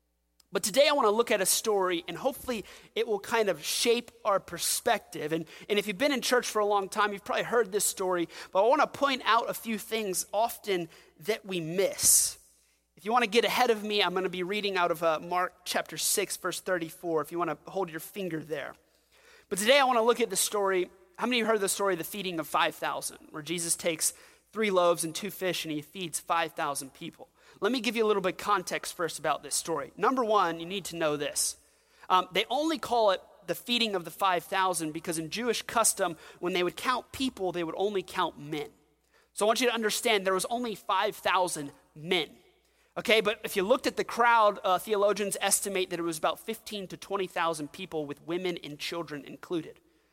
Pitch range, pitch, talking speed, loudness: 170-225 Hz, 190 Hz, 225 wpm, -29 LUFS